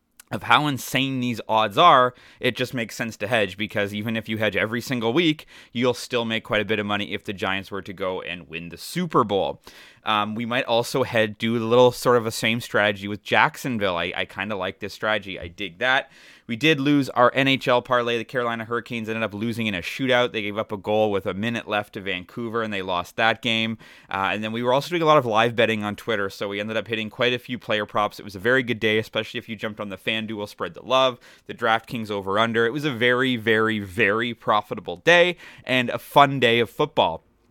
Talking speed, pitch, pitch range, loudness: 245 wpm, 115 Hz, 105-125 Hz, -22 LUFS